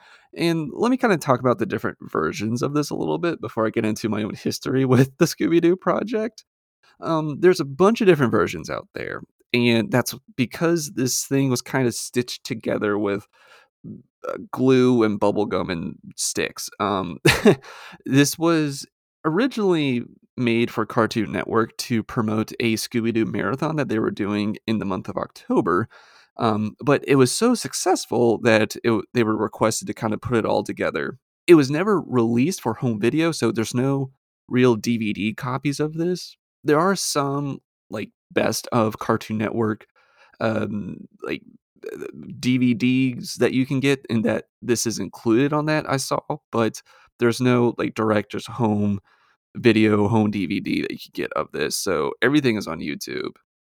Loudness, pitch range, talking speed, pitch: -22 LUFS, 110-145 Hz, 165 wpm, 125 Hz